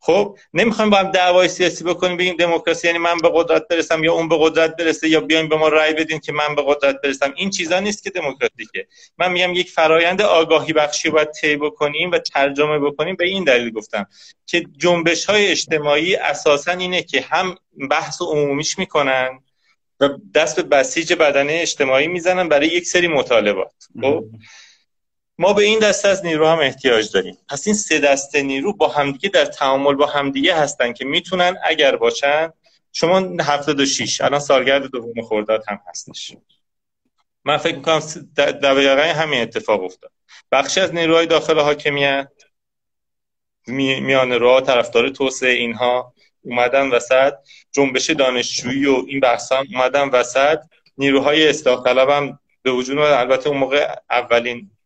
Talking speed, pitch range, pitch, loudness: 160 wpm, 135-170 Hz, 150 Hz, -17 LUFS